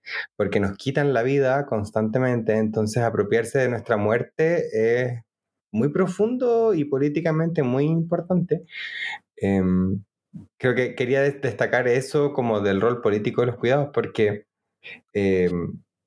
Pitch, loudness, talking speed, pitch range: 125 Hz, -23 LUFS, 125 wpm, 110-145 Hz